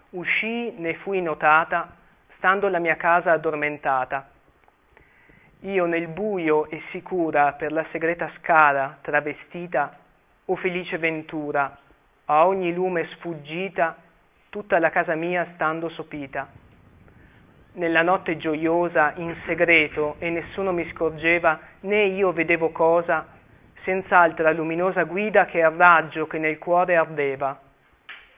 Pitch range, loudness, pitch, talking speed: 155-175 Hz, -22 LUFS, 165 Hz, 115 wpm